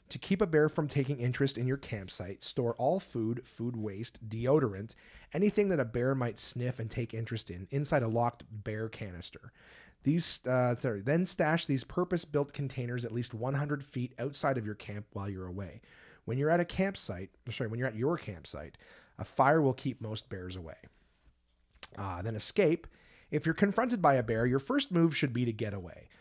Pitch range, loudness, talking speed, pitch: 110-145 Hz, -33 LUFS, 195 wpm, 125 Hz